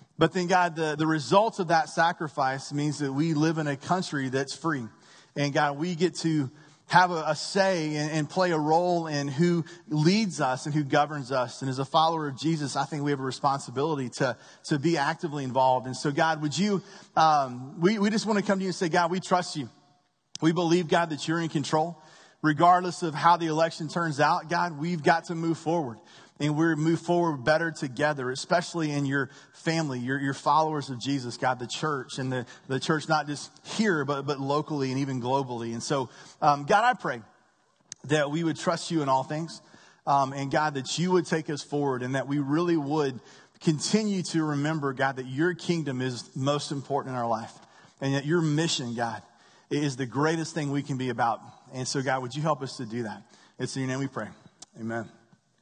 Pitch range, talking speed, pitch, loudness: 135-165 Hz, 215 wpm, 150 Hz, -27 LUFS